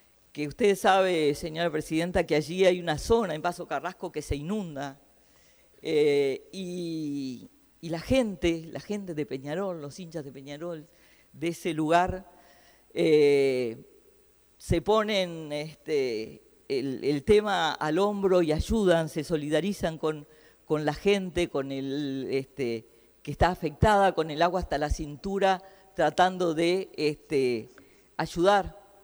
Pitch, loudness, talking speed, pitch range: 170 Hz, -27 LUFS, 130 wpm, 150-195 Hz